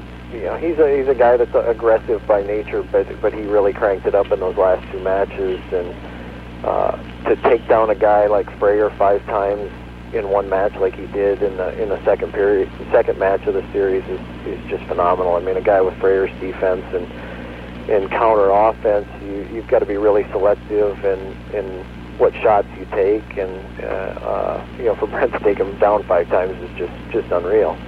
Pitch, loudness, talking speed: 105 Hz, -18 LUFS, 210 wpm